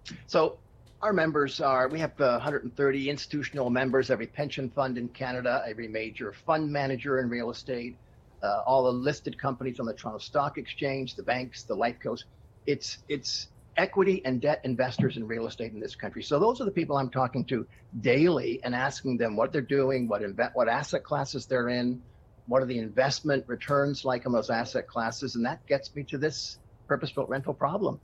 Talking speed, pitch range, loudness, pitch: 195 wpm, 120-140 Hz, -29 LUFS, 130 Hz